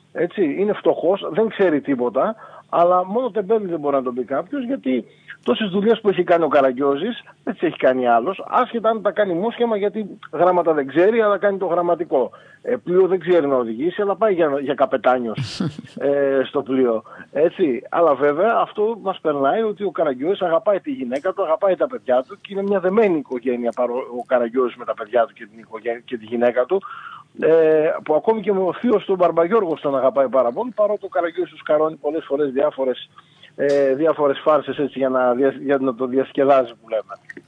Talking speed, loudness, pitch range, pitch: 200 wpm, -20 LUFS, 135-205 Hz, 160 Hz